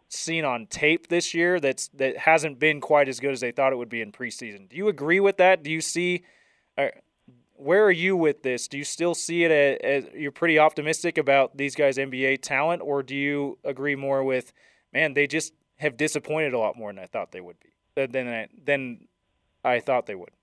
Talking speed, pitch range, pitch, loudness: 225 wpm, 135-165 Hz, 150 Hz, -24 LUFS